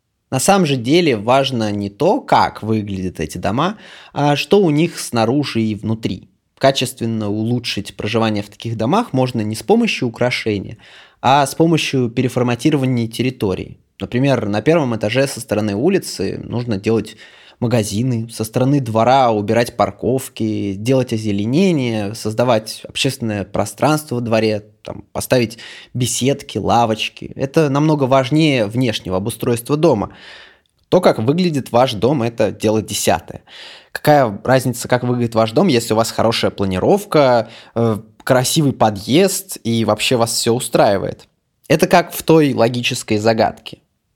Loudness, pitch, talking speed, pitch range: -17 LUFS, 120 Hz, 135 wpm, 110-135 Hz